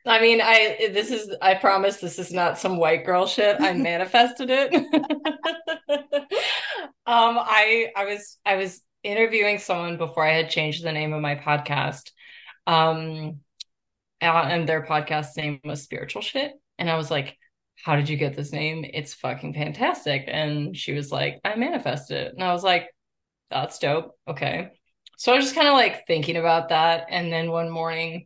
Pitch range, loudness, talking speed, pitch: 155-225 Hz, -23 LUFS, 175 wpm, 170 Hz